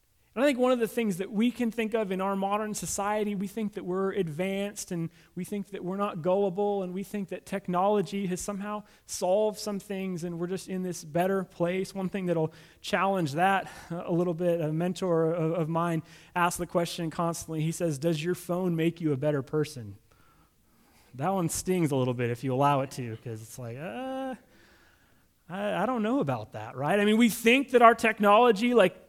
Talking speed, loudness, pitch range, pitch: 205 wpm, -28 LUFS, 165-205 Hz, 185 Hz